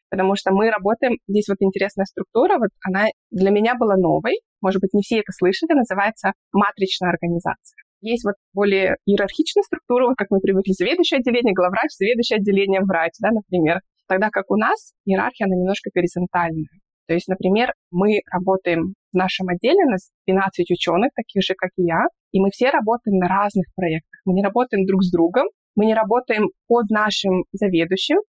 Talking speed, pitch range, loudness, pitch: 180 wpm, 185-225 Hz, -20 LUFS, 195 Hz